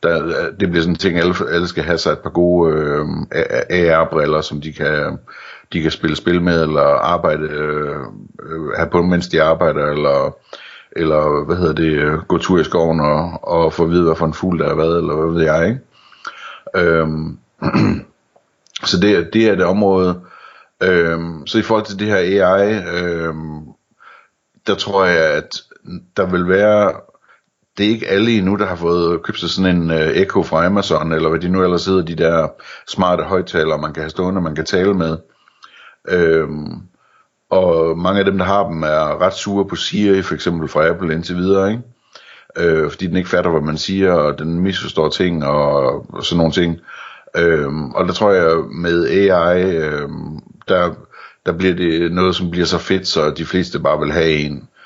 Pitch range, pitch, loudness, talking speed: 80-90 Hz, 85 Hz, -16 LUFS, 190 wpm